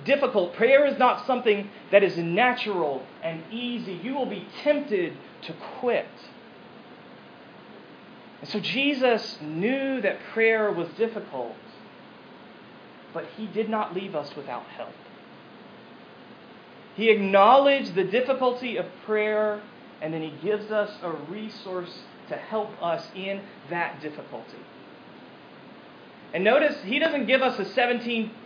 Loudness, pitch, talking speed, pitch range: -25 LUFS, 220 Hz, 125 wpm, 195-245 Hz